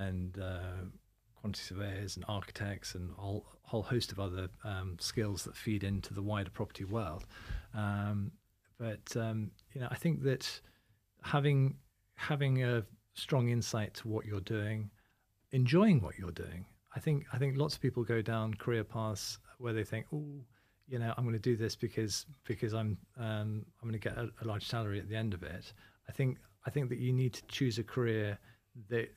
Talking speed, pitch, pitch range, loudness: 190 wpm, 110 Hz, 100-120 Hz, -37 LUFS